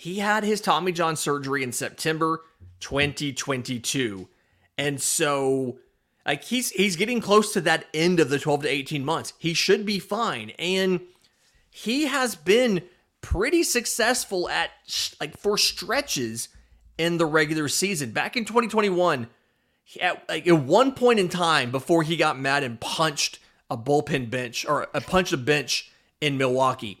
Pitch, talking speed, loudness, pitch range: 160 Hz, 155 wpm, -24 LUFS, 135-190 Hz